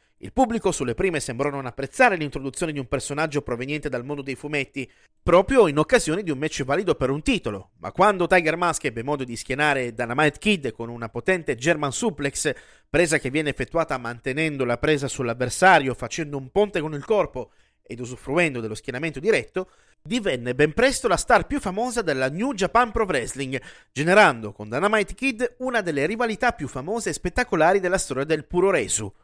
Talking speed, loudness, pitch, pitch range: 180 wpm, -23 LUFS, 150 Hz, 135-190 Hz